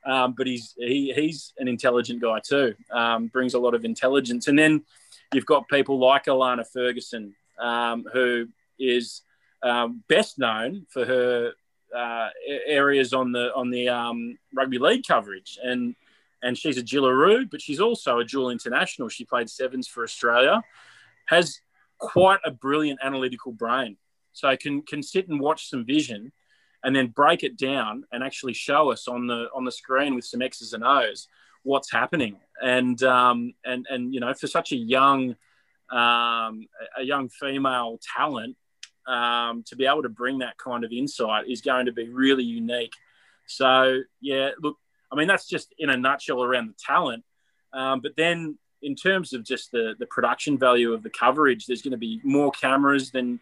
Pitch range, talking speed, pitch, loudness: 120-140 Hz, 175 wpm, 130 Hz, -24 LUFS